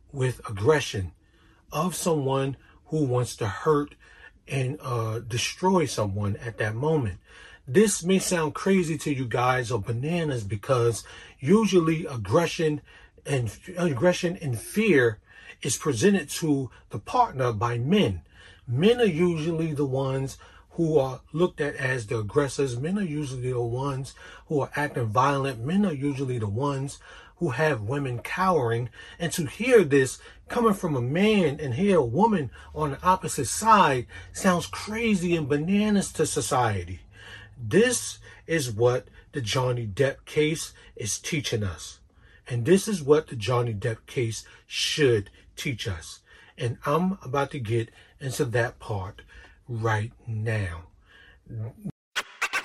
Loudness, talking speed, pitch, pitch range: -26 LUFS, 140 wpm, 135 Hz, 115-165 Hz